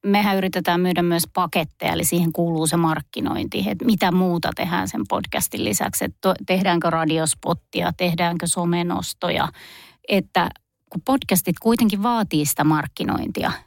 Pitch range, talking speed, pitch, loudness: 170-190 Hz, 125 wpm, 175 Hz, -21 LUFS